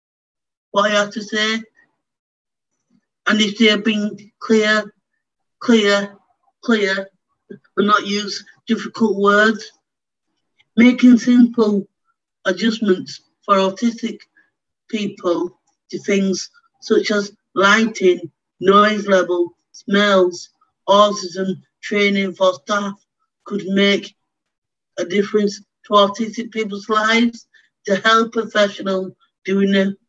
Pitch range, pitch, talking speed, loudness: 195-225 Hz, 205 Hz, 100 wpm, -17 LUFS